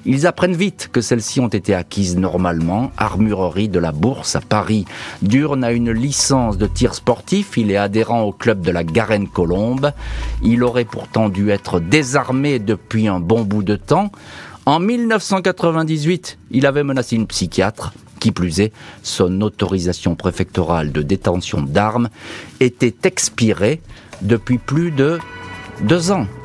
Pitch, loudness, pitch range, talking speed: 110 Hz, -17 LUFS, 100-135 Hz, 145 wpm